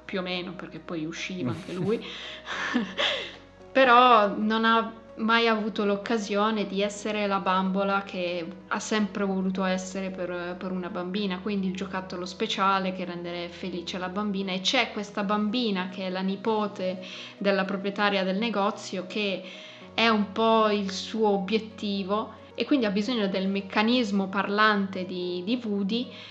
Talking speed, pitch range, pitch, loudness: 145 wpm, 185-220 Hz, 200 Hz, -27 LUFS